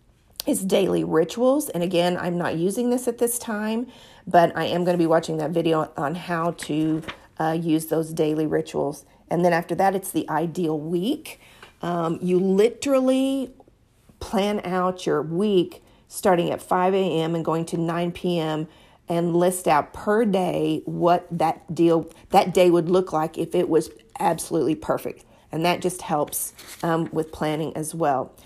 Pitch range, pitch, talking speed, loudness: 160-185 Hz, 170 Hz, 170 wpm, -23 LUFS